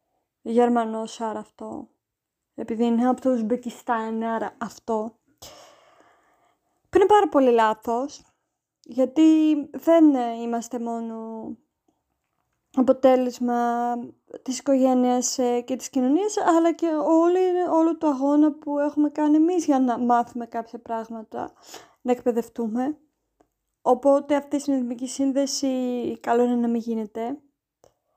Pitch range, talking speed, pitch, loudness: 235-290 Hz, 110 wpm, 255 Hz, -23 LUFS